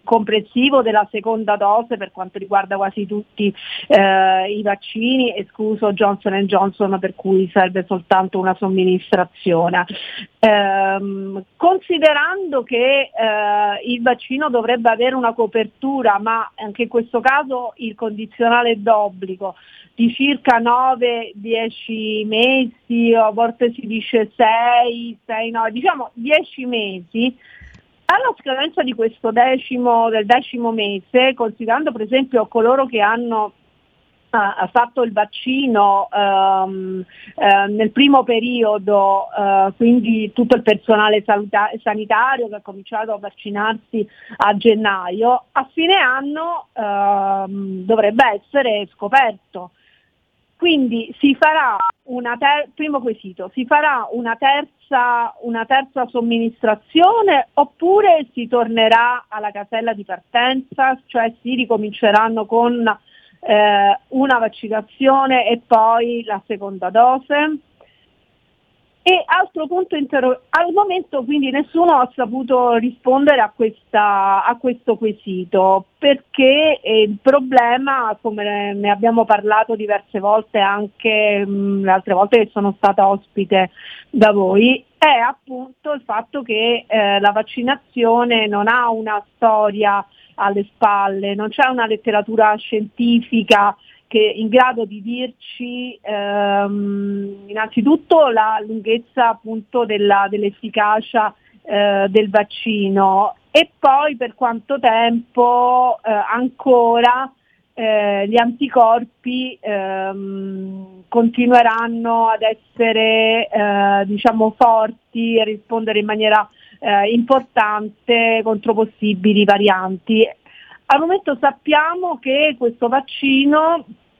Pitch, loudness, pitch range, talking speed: 225 Hz, -16 LUFS, 205-250 Hz, 110 wpm